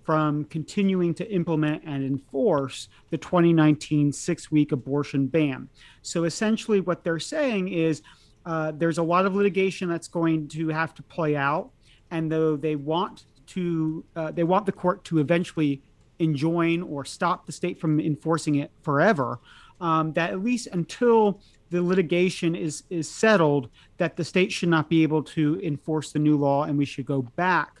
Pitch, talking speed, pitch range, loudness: 160 Hz, 170 wpm, 150-175 Hz, -25 LUFS